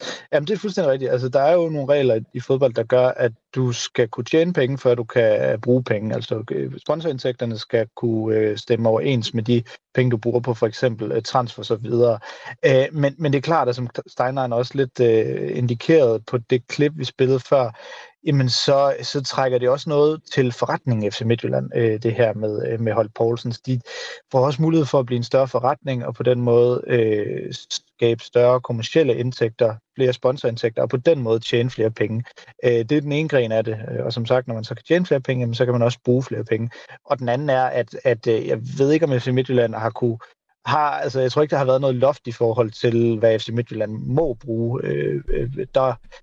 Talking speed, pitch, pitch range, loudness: 215 wpm, 125 Hz, 115-135 Hz, -21 LUFS